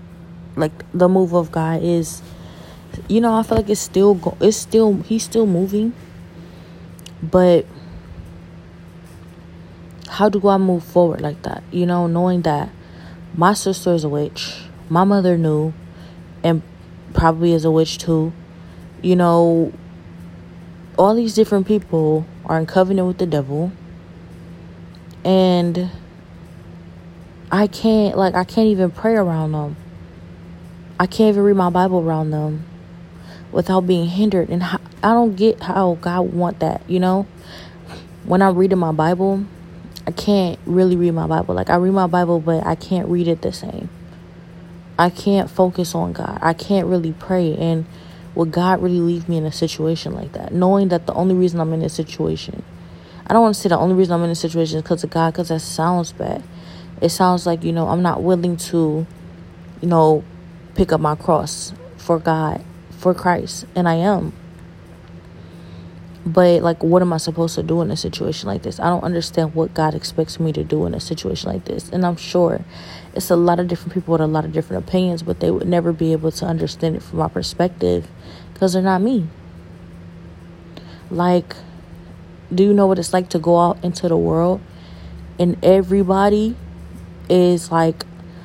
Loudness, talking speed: -18 LUFS, 175 wpm